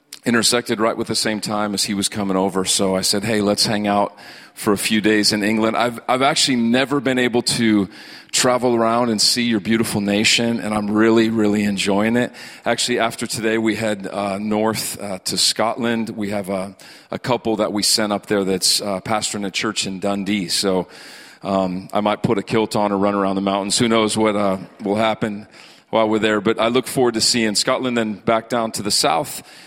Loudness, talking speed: -18 LUFS, 215 wpm